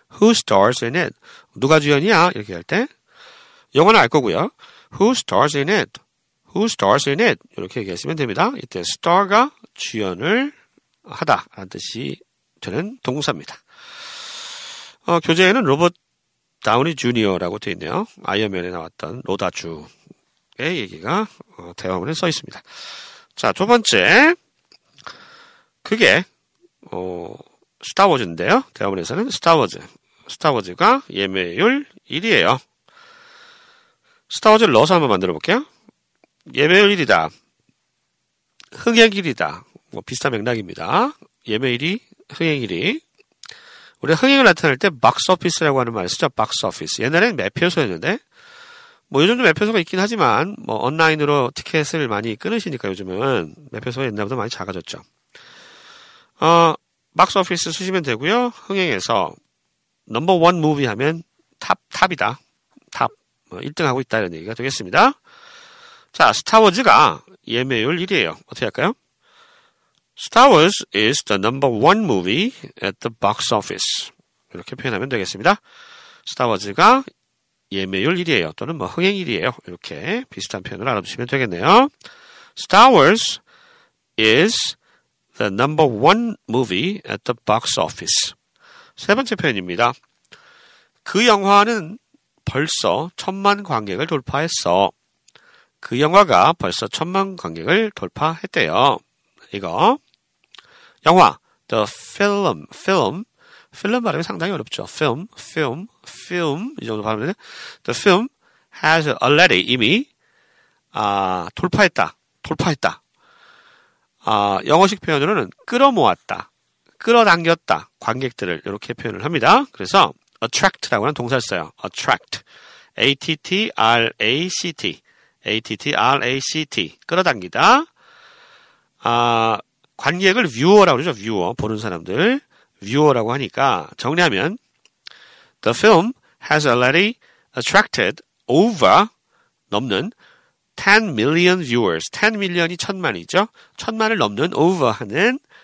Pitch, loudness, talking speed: 185 Hz, -17 LUFS, 325 characters per minute